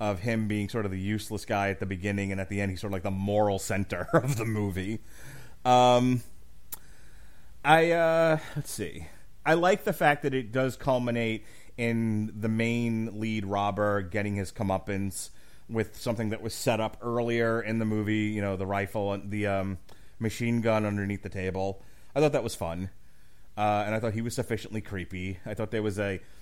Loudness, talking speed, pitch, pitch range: -29 LUFS, 195 wpm, 105 Hz, 100-115 Hz